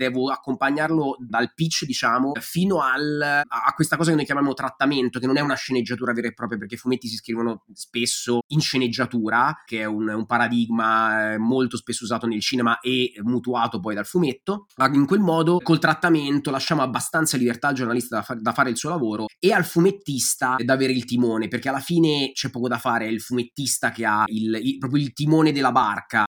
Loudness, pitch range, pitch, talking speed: -22 LUFS, 120-145 Hz, 130 Hz, 200 wpm